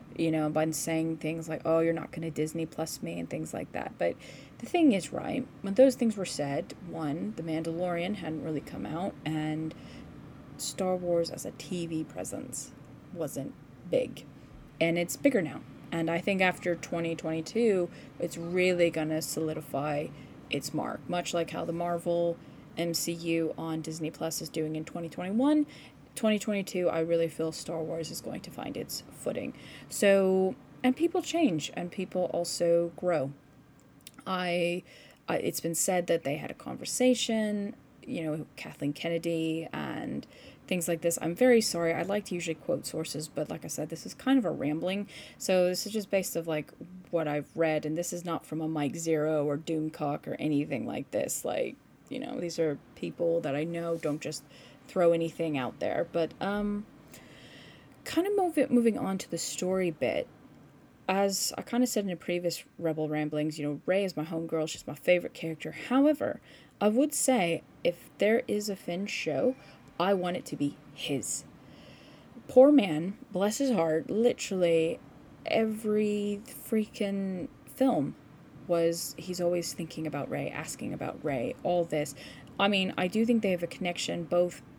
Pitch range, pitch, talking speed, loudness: 155-195 Hz, 170 Hz, 175 wpm, -31 LUFS